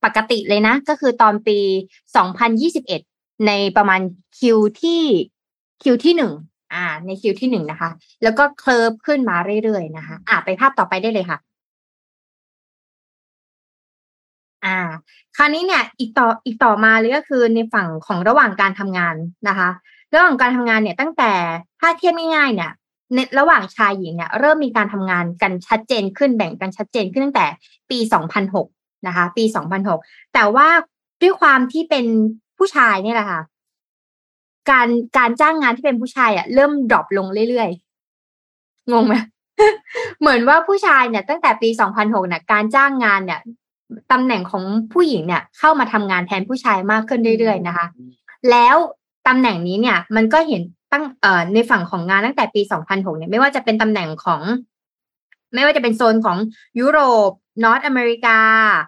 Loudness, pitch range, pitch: -16 LUFS, 195-265 Hz, 225 Hz